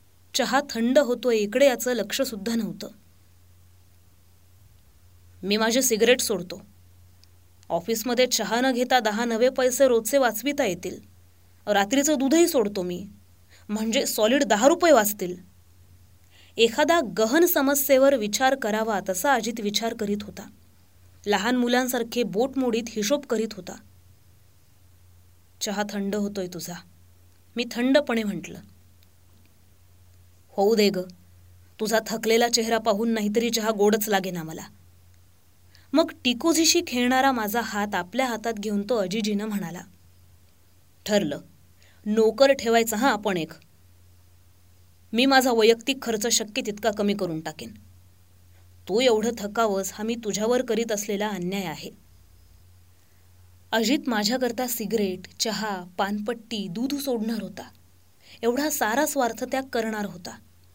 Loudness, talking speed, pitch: -24 LUFS, 115 wpm, 210 Hz